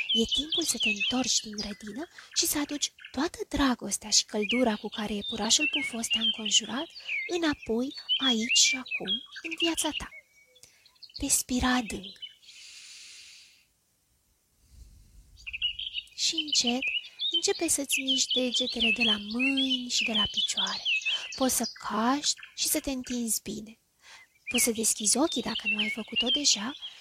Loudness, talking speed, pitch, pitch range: -27 LUFS, 135 wpm, 245 Hz, 215-290 Hz